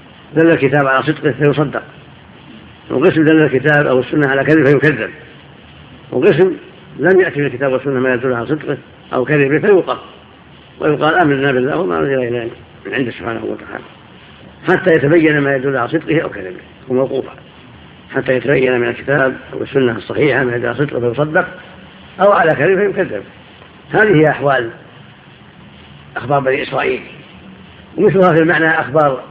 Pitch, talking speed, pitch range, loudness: 145 Hz, 145 wpm, 130-160 Hz, -14 LUFS